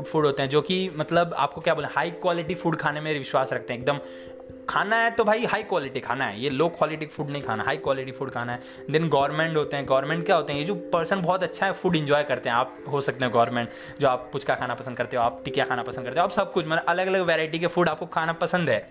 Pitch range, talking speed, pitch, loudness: 130-175 Hz, 270 wpm, 155 Hz, -25 LUFS